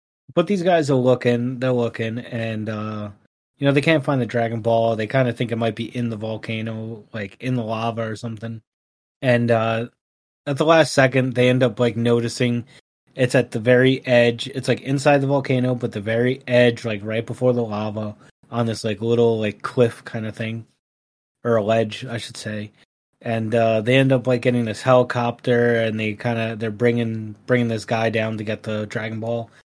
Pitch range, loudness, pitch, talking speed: 110-125 Hz, -21 LUFS, 115 Hz, 205 wpm